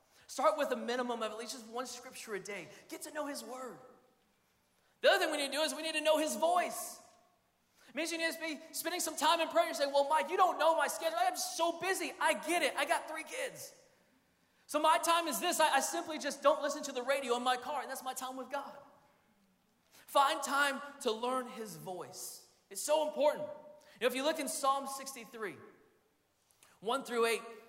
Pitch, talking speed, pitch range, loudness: 290 Hz, 225 wpm, 255-320 Hz, -34 LUFS